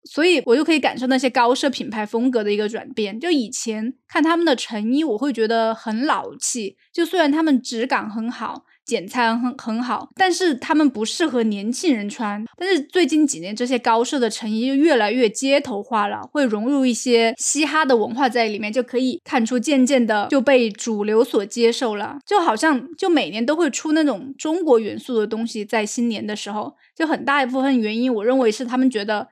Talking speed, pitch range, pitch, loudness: 310 characters per minute, 225-285 Hz, 250 Hz, -20 LUFS